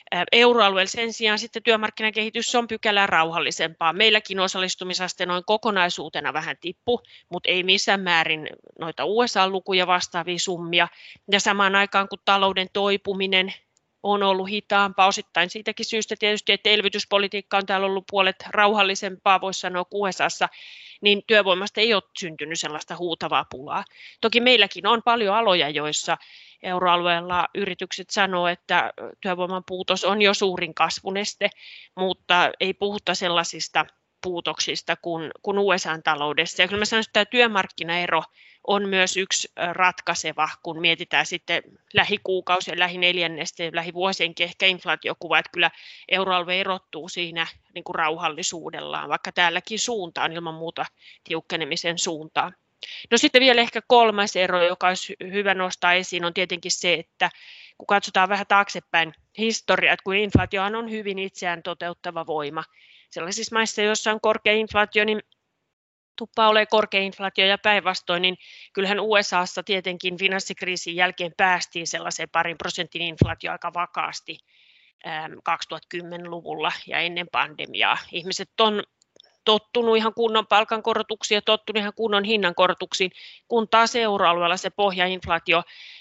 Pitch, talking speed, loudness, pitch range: 190 Hz, 130 wpm, -22 LUFS, 175-205 Hz